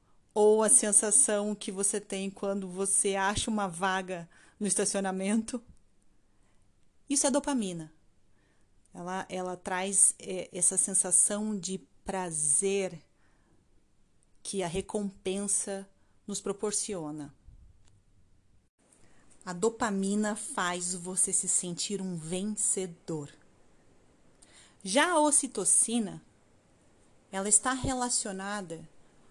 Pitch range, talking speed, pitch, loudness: 170-210 Hz, 90 wpm, 195 Hz, -28 LUFS